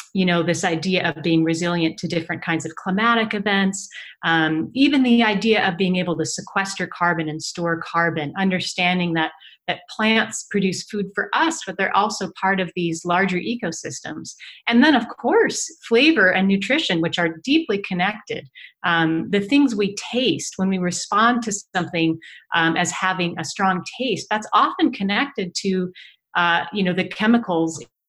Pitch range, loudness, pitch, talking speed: 170-210 Hz, -20 LUFS, 185 Hz, 165 wpm